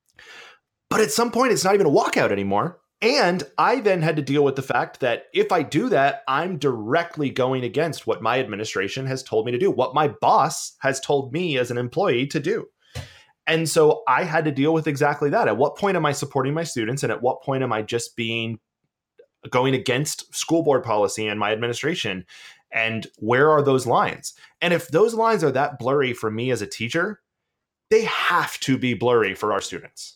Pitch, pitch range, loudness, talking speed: 145 Hz, 120-170 Hz, -22 LUFS, 210 wpm